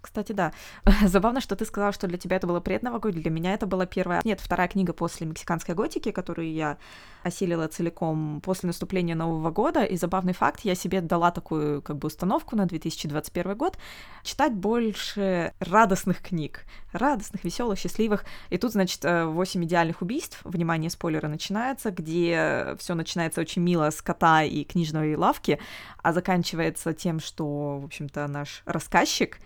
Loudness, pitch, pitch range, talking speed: -27 LUFS, 175 Hz, 165-195 Hz, 160 wpm